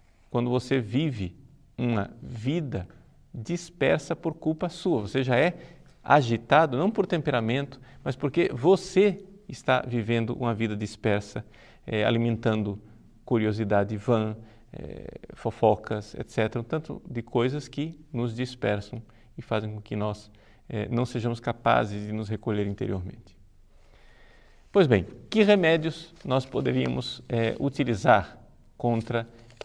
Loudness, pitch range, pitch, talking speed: -27 LUFS, 110-145 Hz, 120 Hz, 120 wpm